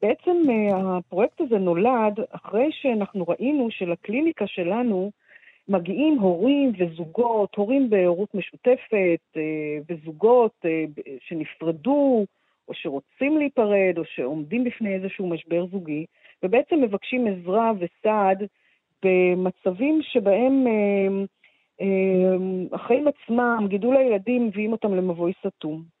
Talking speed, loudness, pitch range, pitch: 90 wpm, -23 LUFS, 180-240 Hz, 200 Hz